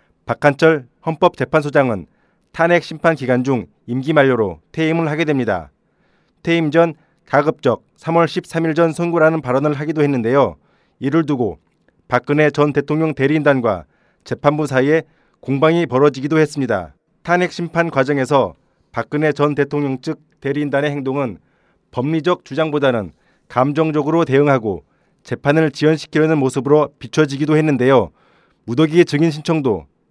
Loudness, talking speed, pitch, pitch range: -17 LUFS, 315 characters per minute, 150 Hz, 135-160 Hz